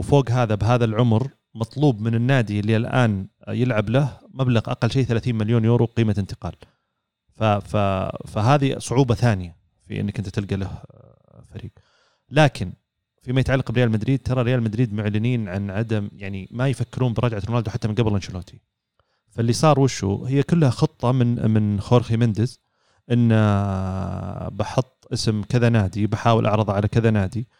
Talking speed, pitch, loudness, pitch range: 150 wpm, 115 Hz, -21 LUFS, 105-125 Hz